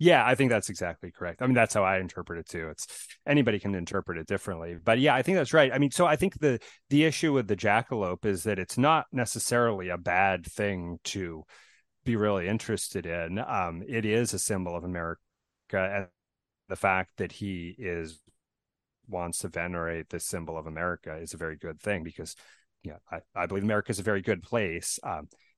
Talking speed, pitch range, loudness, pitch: 205 wpm, 85-115 Hz, -29 LUFS, 100 Hz